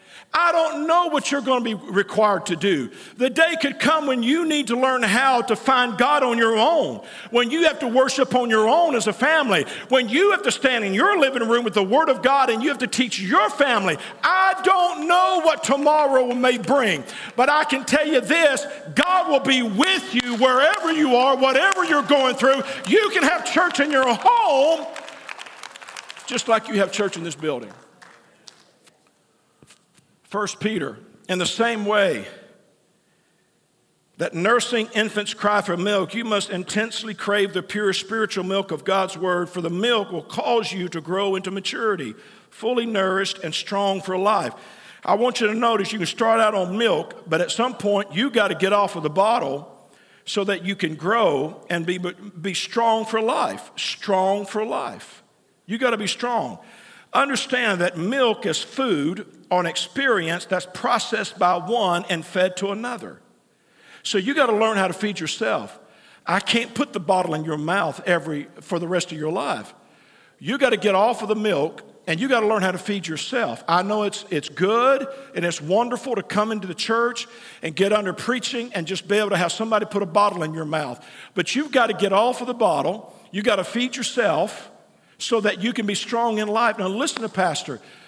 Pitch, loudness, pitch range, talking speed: 220 Hz, -21 LUFS, 195-260 Hz, 195 wpm